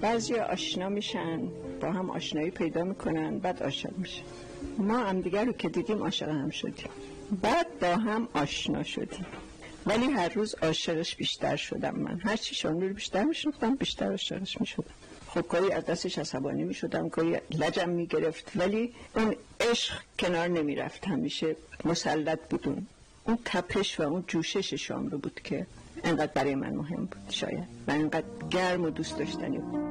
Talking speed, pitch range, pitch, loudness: 155 wpm, 165-220 Hz, 185 Hz, -31 LUFS